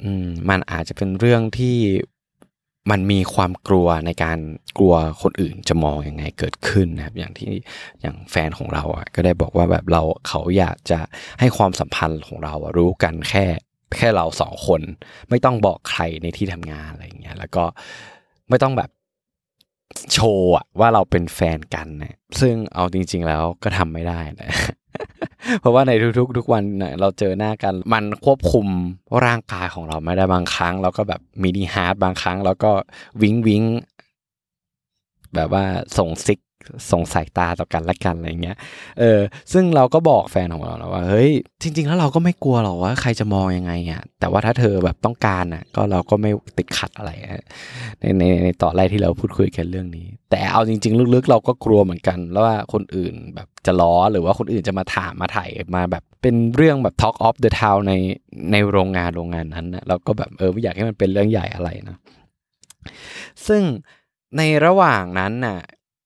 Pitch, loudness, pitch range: 95 Hz, -19 LUFS, 85-110 Hz